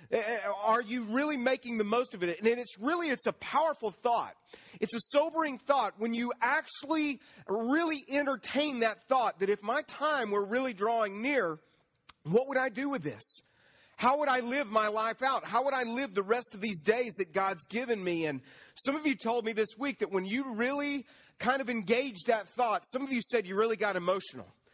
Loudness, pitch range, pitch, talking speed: -31 LUFS, 215-275 Hz, 240 Hz, 205 wpm